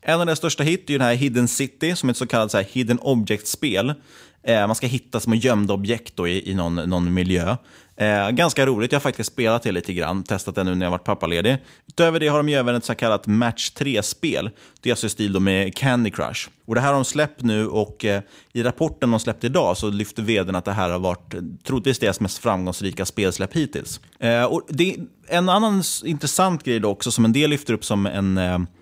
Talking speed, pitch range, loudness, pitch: 235 wpm, 100-135 Hz, -21 LUFS, 115 Hz